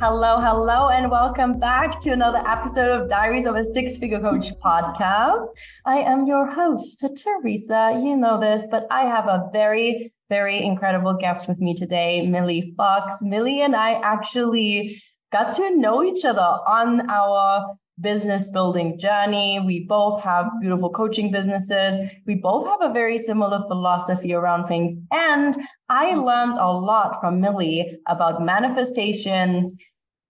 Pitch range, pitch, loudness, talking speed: 190-240 Hz, 210 Hz, -20 LUFS, 150 wpm